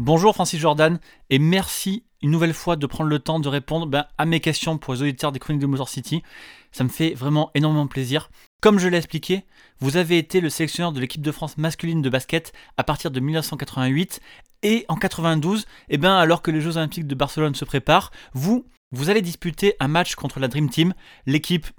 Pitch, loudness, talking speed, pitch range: 160 Hz, -22 LUFS, 210 wpm, 145-170 Hz